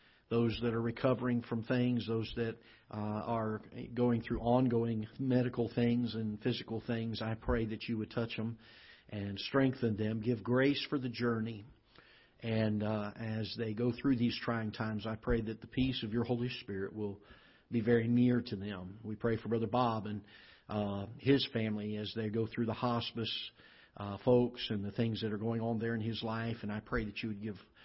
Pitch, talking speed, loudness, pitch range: 115 Hz, 200 wpm, -35 LUFS, 110-120 Hz